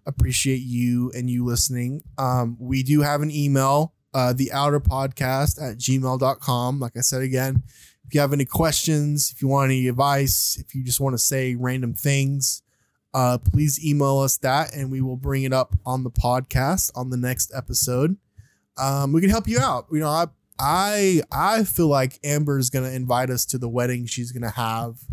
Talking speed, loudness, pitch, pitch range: 195 wpm, -22 LUFS, 130 Hz, 125-140 Hz